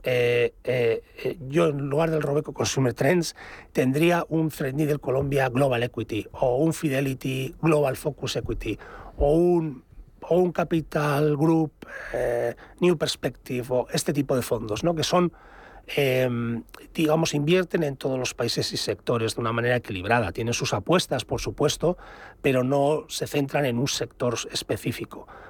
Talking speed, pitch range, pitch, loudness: 150 wpm, 125-160 Hz, 145 Hz, -25 LUFS